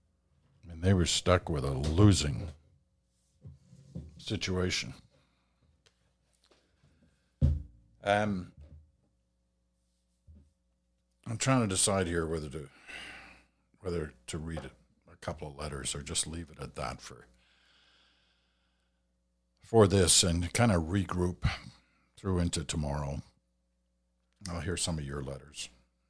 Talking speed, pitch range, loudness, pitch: 105 wpm, 60-90 Hz, -30 LUFS, 75 Hz